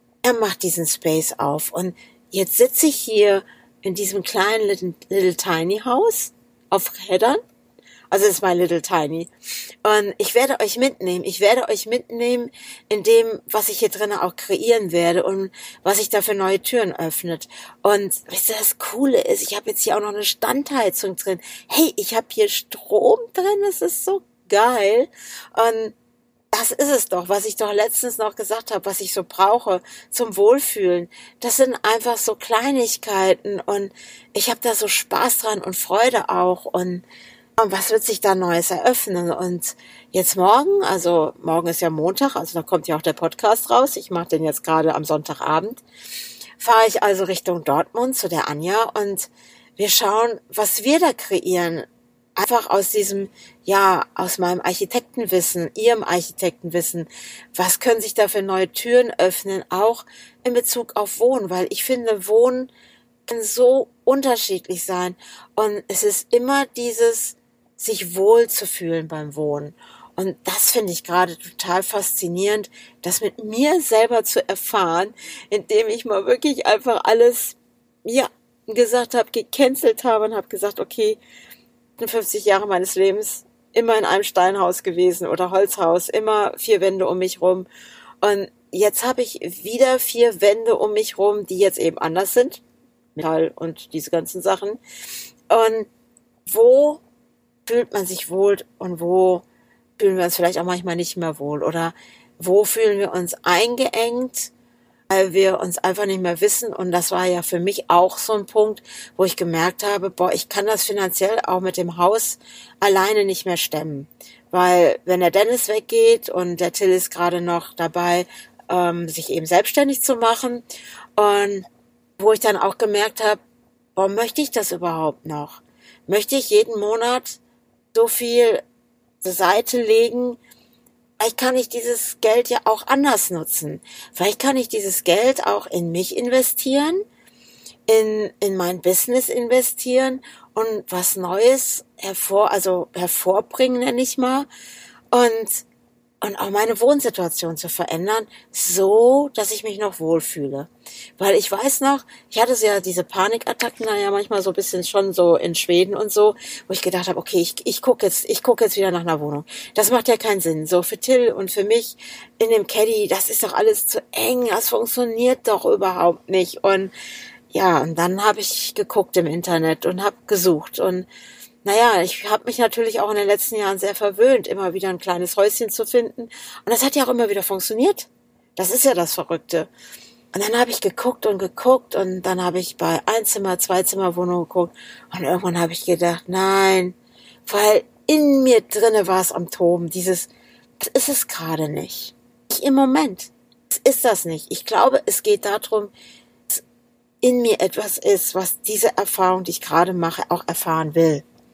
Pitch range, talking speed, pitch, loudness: 180-235 Hz, 170 wpm, 205 Hz, -19 LUFS